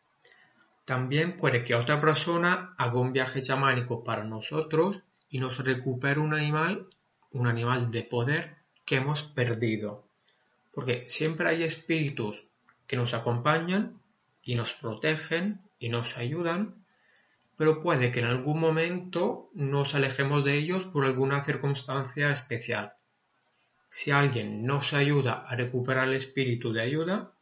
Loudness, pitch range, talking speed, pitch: -29 LUFS, 125-160 Hz, 130 wpm, 140 Hz